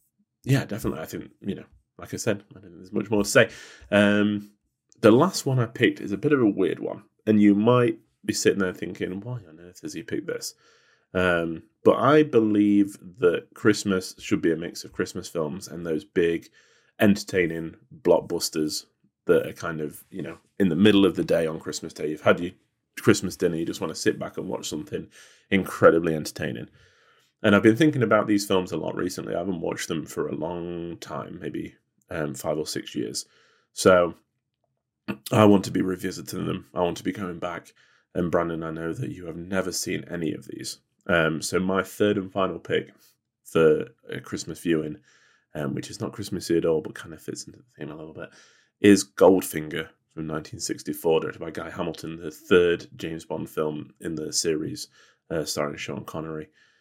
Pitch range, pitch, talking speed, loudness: 80-105 Hz, 95 Hz, 200 wpm, -25 LUFS